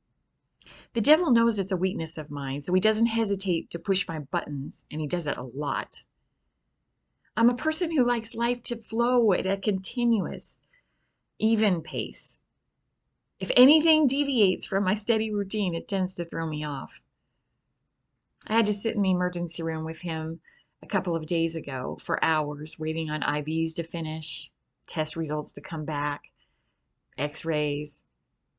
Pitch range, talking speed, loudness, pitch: 155-220 Hz, 160 wpm, -27 LUFS, 175 Hz